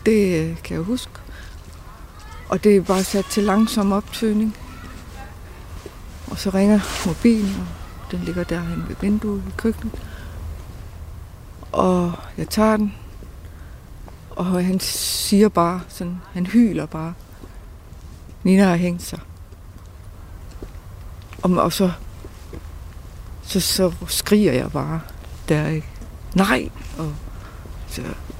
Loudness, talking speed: -20 LUFS, 110 wpm